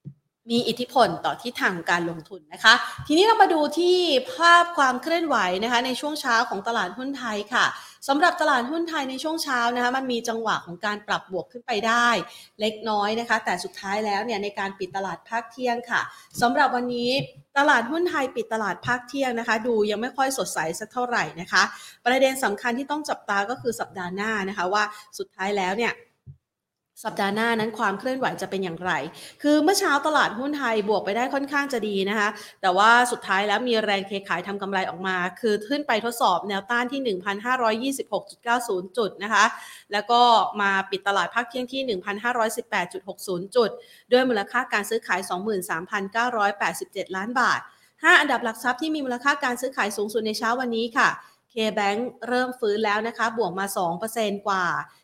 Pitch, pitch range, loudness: 230 Hz, 200-250 Hz, -23 LUFS